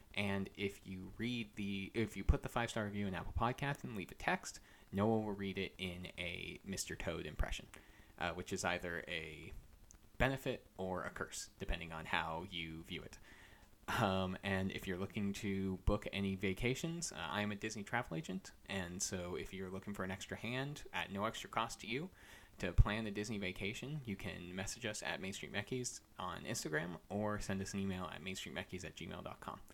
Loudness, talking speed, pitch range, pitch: -42 LUFS, 200 wpm, 95-105 Hz, 100 Hz